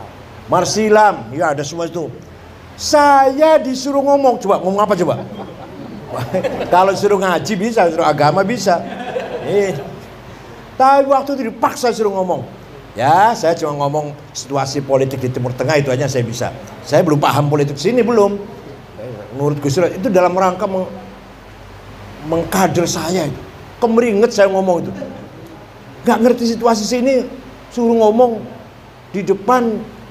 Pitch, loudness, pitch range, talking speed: 185 Hz, -15 LUFS, 145-230 Hz, 130 wpm